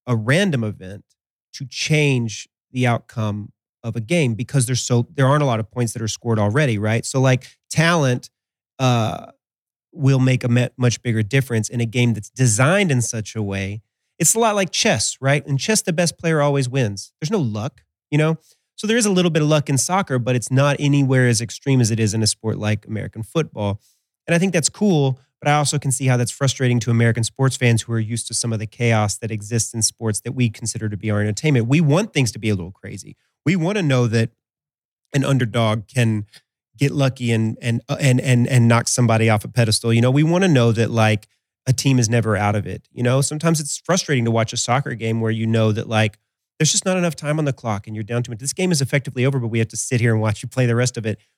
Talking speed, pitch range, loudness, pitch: 250 wpm, 110-140 Hz, -19 LUFS, 120 Hz